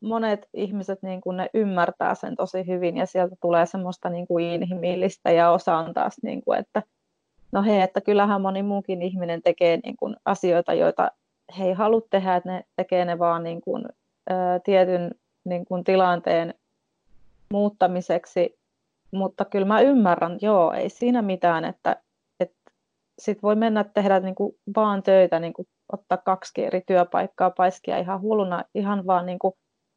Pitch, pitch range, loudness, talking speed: 185 Hz, 180-200 Hz, -23 LUFS, 160 wpm